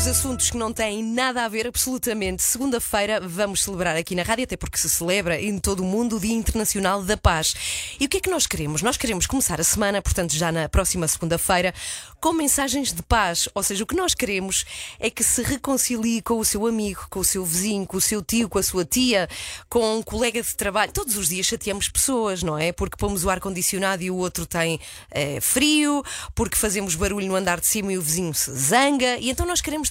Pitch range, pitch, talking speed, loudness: 185-235 Hz, 205 Hz, 225 wpm, -22 LUFS